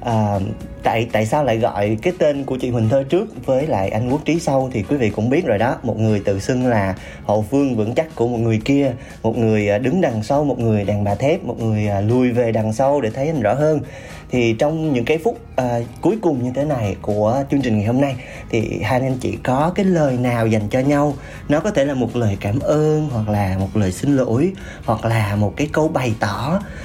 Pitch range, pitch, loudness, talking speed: 110-140 Hz, 125 Hz, -19 LUFS, 245 wpm